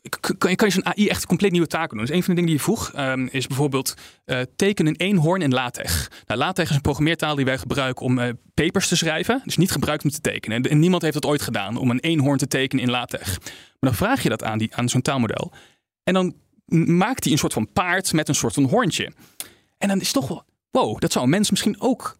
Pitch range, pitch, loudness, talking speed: 130-180 Hz, 155 Hz, -21 LUFS, 260 wpm